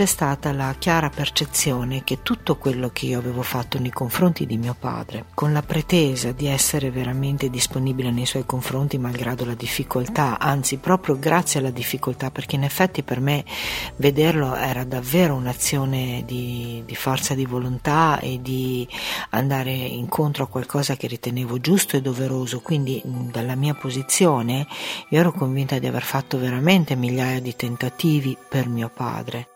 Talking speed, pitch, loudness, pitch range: 155 wpm, 130 Hz, -22 LUFS, 125-145 Hz